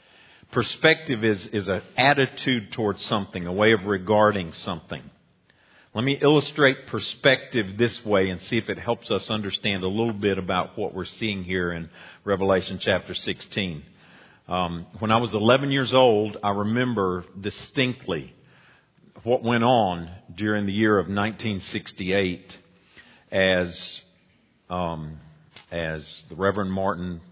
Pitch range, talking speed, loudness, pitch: 95-115 Hz, 135 wpm, -24 LUFS, 105 Hz